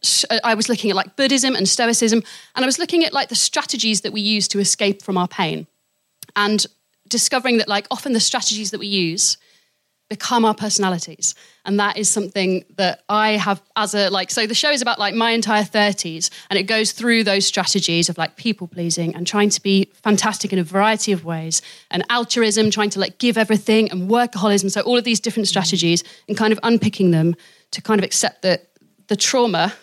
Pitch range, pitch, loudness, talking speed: 190-225 Hz, 210 Hz, -18 LUFS, 205 wpm